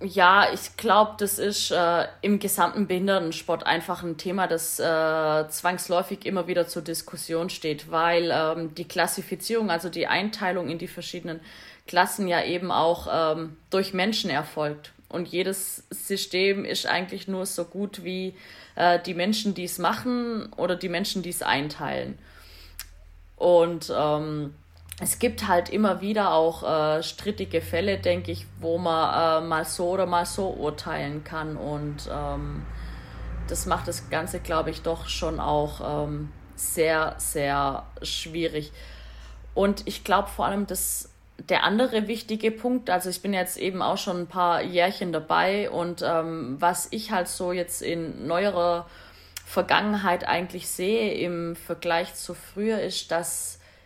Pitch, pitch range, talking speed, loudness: 175 Hz, 160-185 Hz, 150 wpm, -26 LUFS